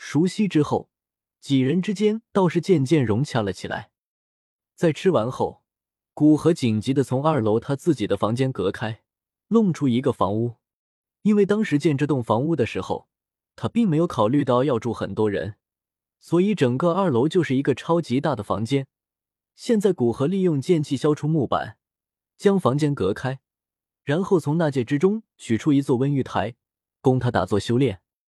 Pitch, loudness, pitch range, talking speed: 140 Hz, -22 LUFS, 120-170 Hz, 255 characters per minute